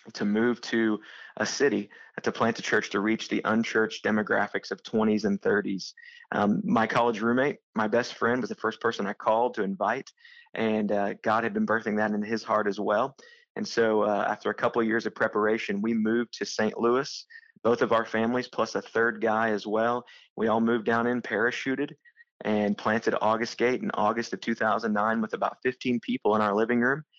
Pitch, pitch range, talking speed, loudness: 115 Hz, 110-125 Hz, 205 wpm, -27 LUFS